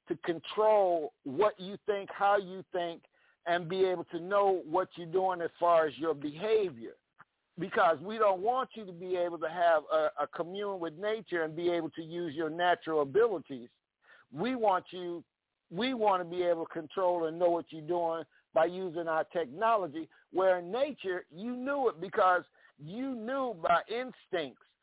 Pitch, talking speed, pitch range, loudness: 180 Hz, 180 wpm, 165-210 Hz, -32 LUFS